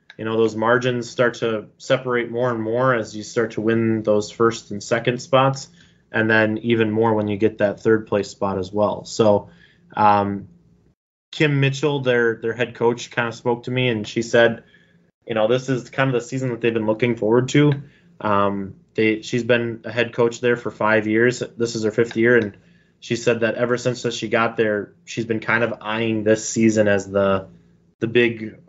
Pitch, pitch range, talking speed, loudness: 115 Hz, 110-120 Hz, 205 wpm, -20 LUFS